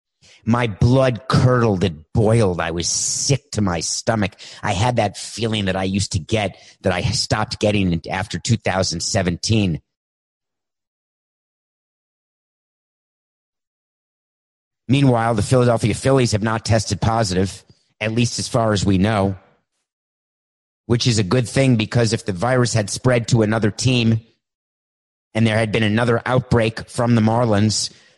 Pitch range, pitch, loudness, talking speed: 100-120 Hz, 110 Hz, -19 LUFS, 135 wpm